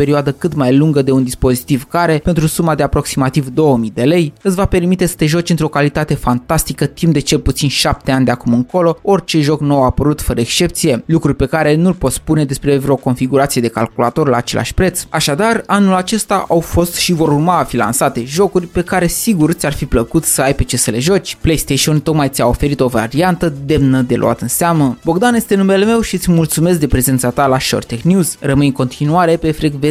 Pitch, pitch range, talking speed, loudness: 150 Hz, 130-170 Hz, 220 wpm, -13 LUFS